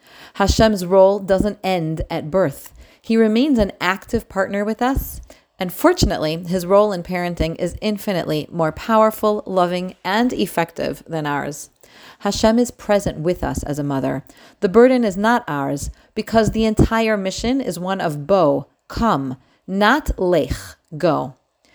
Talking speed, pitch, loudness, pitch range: 145 wpm, 195 Hz, -19 LUFS, 170-220 Hz